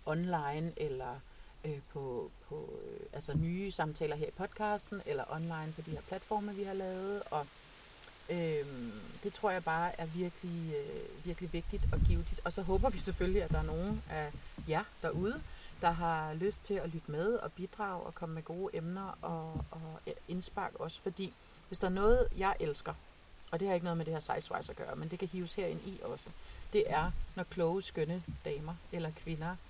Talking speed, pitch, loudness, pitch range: 200 wpm, 170 Hz, -38 LUFS, 155-195 Hz